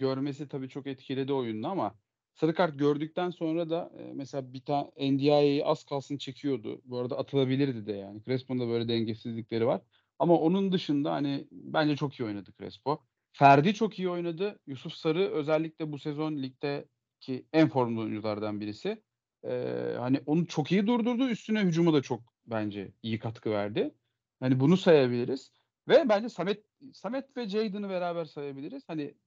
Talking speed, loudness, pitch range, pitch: 160 wpm, -30 LUFS, 125-165 Hz, 140 Hz